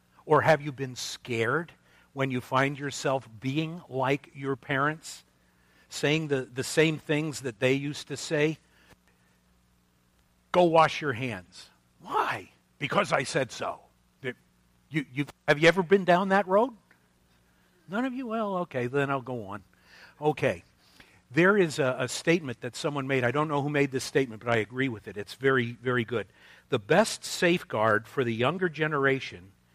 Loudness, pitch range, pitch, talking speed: -27 LUFS, 100-150 Hz, 135 Hz, 165 wpm